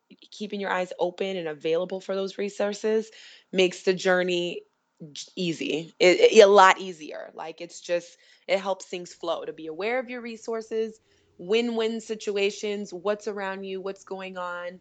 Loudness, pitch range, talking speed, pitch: -25 LUFS, 175-210 Hz, 160 wpm, 190 Hz